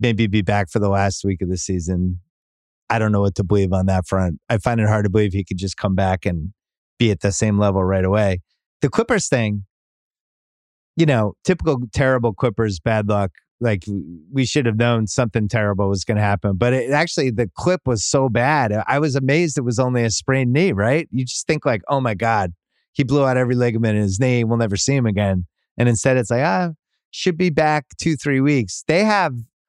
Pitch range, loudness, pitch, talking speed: 100-135 Hz, -19 LUFS, 115 Hz, 220 wpm